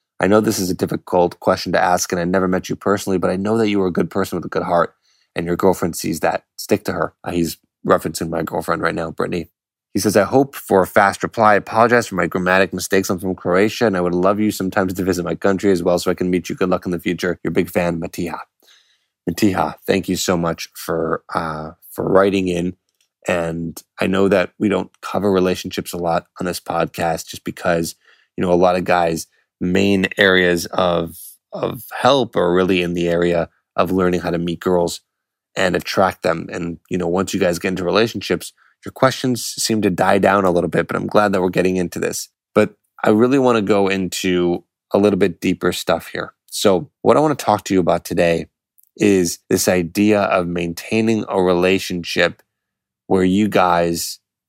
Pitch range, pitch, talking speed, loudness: 85-100 Hz, 90 Hz, 215 wpm, -18 LUFS